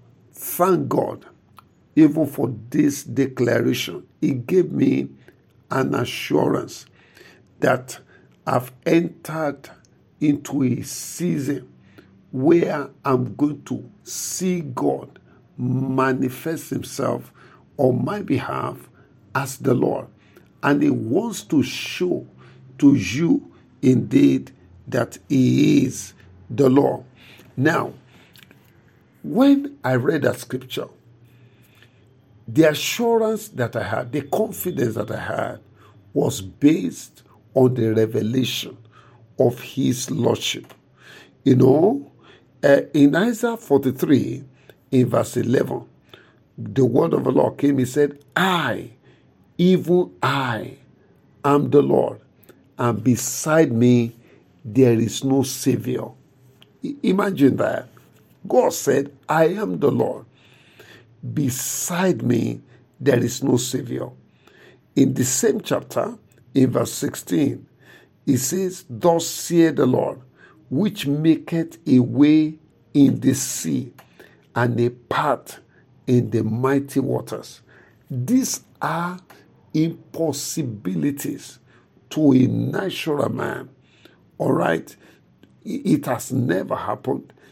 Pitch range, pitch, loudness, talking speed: 120-150 Hz, 130 Hz, -21 LUFS, 105 wpm